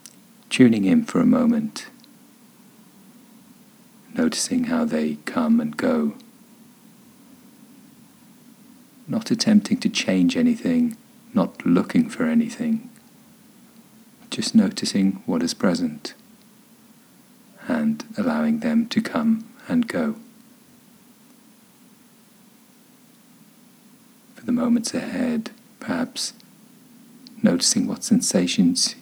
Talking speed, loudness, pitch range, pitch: 85 wpm, -22 LUFS, 230-245 Hz, 235 Hz